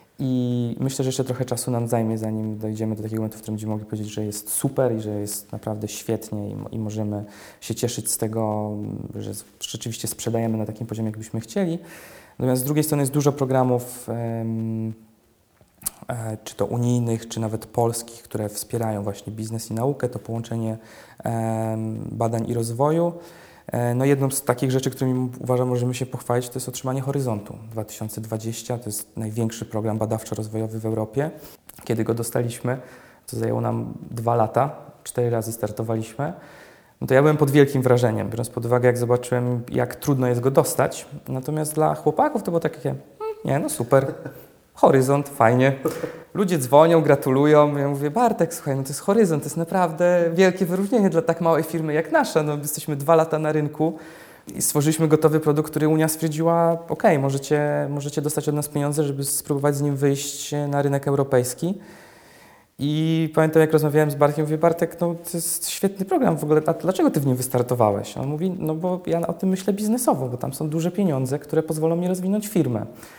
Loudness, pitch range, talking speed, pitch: -23 LUFS, 115-155 Hz, 180 wpm, 130 Hz